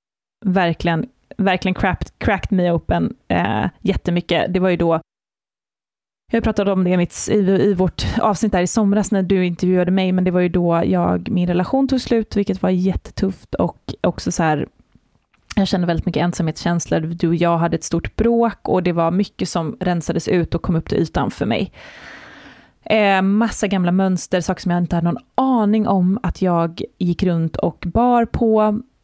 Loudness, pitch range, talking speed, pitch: -19 LUFS, 170-205 Hz, 185 wpm, 185 Hz